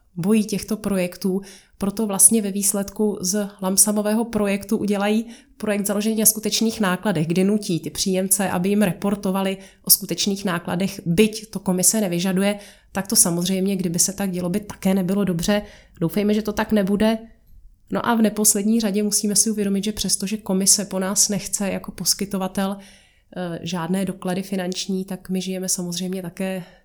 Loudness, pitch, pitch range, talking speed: -20 LUFS, 195 Hz, 185-210 Hz, 160 wpm